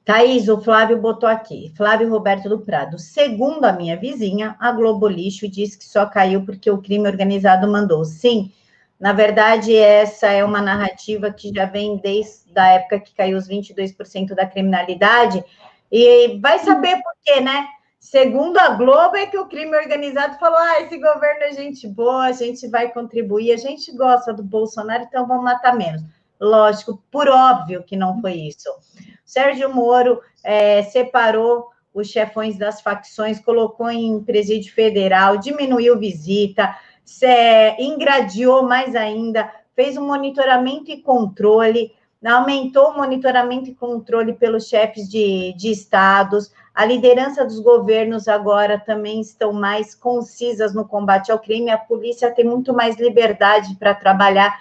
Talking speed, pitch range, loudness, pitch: 155 wpm, 205-250 Hz, -16 LUFS, 220 Hz